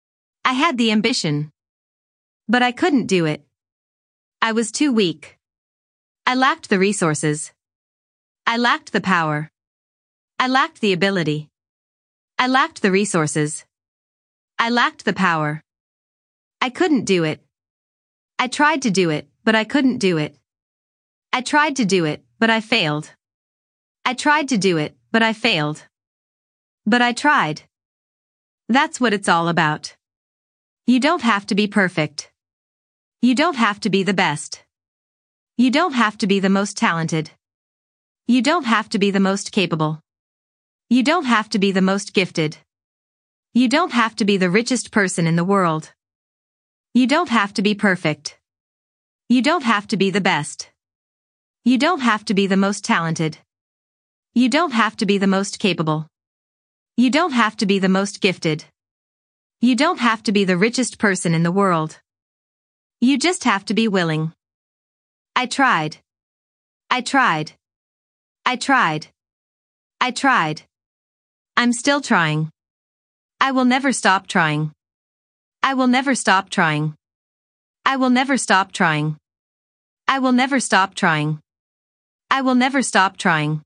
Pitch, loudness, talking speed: 175 Hz, -18 LUFS, 150 wpm